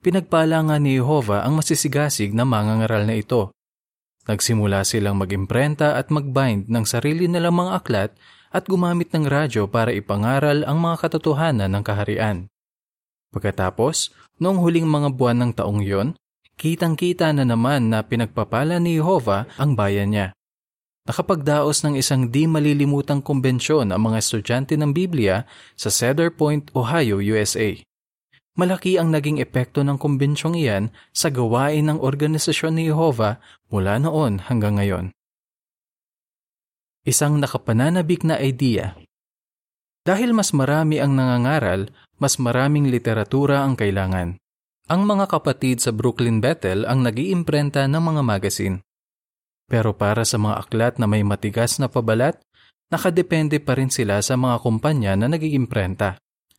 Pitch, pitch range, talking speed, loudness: 130 Hz, 110-155 Hz, 135 wpm, -20 LUFS